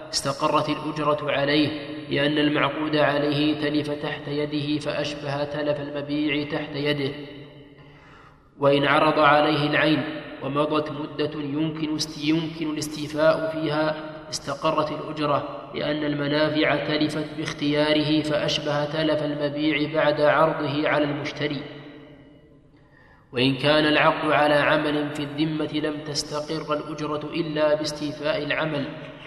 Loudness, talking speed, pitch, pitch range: -24 LUFS, 100 wpm, 150 Hz, 145-155 Hz